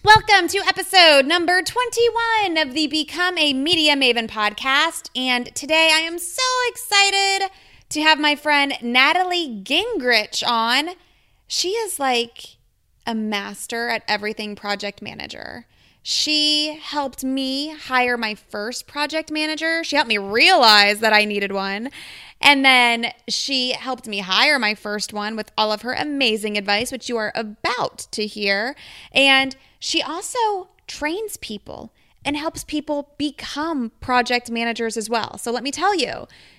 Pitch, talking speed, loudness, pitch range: 275 Hz, 145 wpm, -18 LUFS, 230-325 Hz